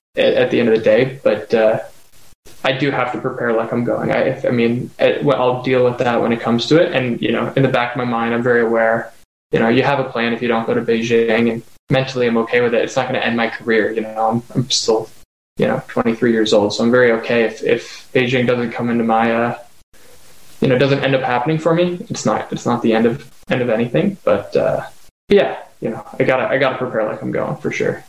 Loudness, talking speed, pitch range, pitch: -17 LUFS, 265 wpm, 115-130 Hz, 120 Hz